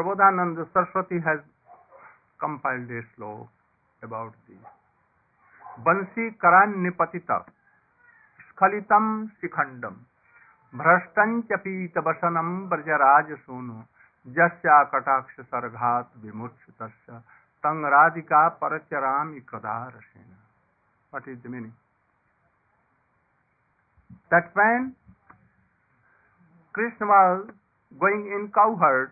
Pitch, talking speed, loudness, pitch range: 165 Hz, 75 wpm, -23 LUFS, 125-190 Hz